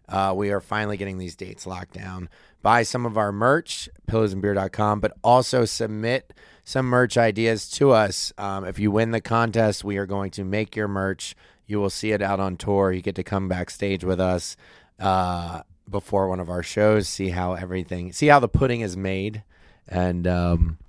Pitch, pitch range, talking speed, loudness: 100 Hz, 90-110 Hz, 190 wpm, -23 LUFS